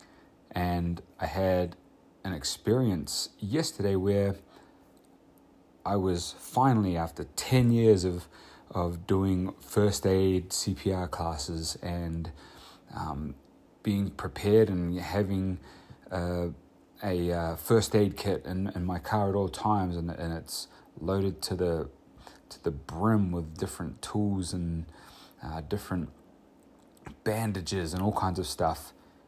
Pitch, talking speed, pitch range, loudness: 95 Hz, 125 wpm, 85-100 Hz, -30 LUFS